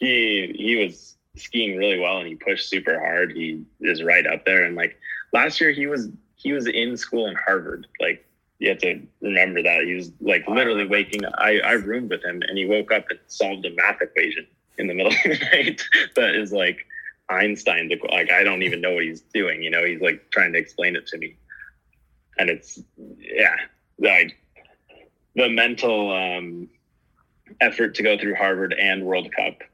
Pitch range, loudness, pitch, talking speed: 90-125 Hz, -20 LUFS, 105 Hz, 195 wpm